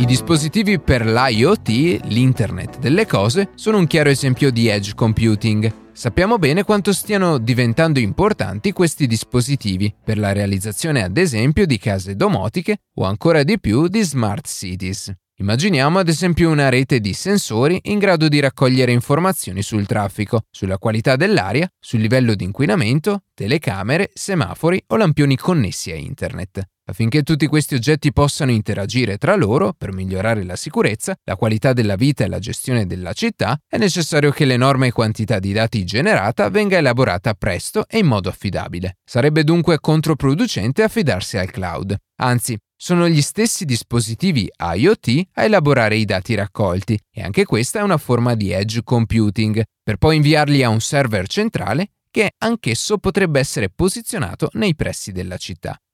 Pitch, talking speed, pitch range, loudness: 130 Hz, 155 wpm, 110-165 Hz, -17 LUFS